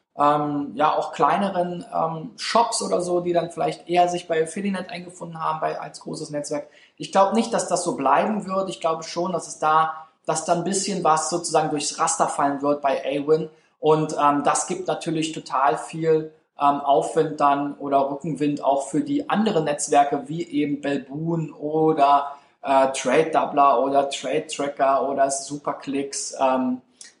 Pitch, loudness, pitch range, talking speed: 155 Hz, -22 LUFS, 140-170 Hz, 170 wpm